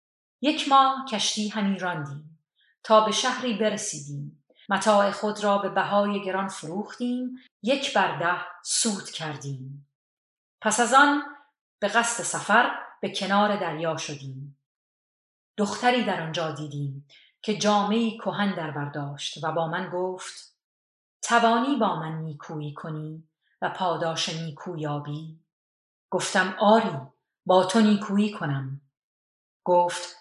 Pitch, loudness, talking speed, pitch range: 185 Hz, -25 LUFS, 115 wpm, 155-215 Hz